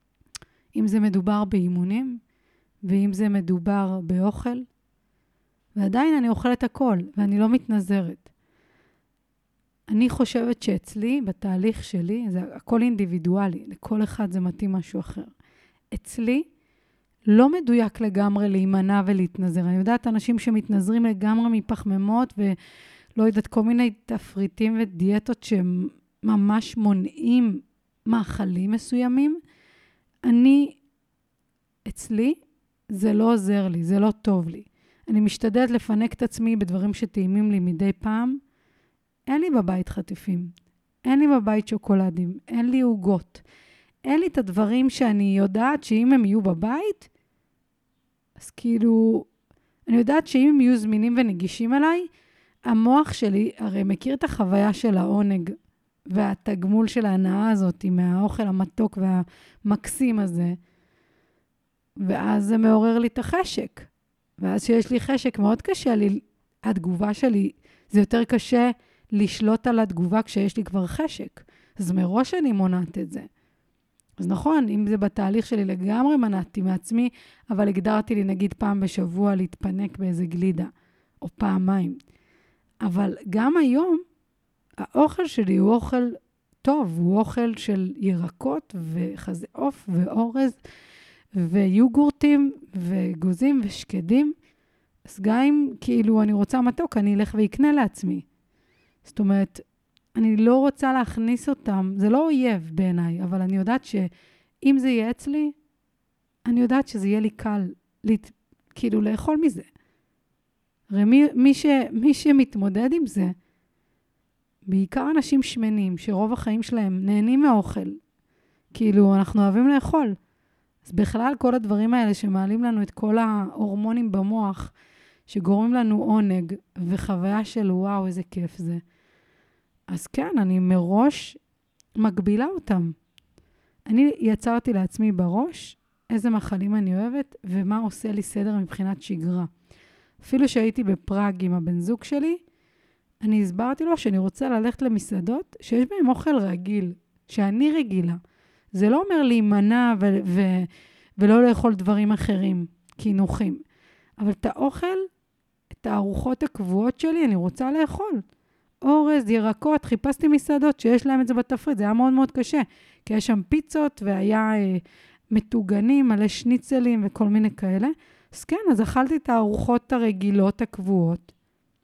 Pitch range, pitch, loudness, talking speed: 195-250 Hz, 215 Hz, -23 LUFS, 125 wpm